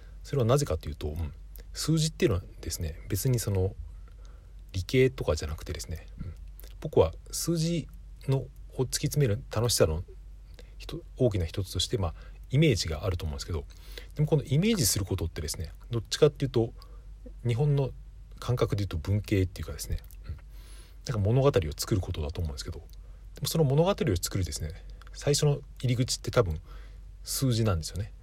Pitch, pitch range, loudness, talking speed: 95 Hz, 85-130 Hz, -29 LUFS, 360 characters per minute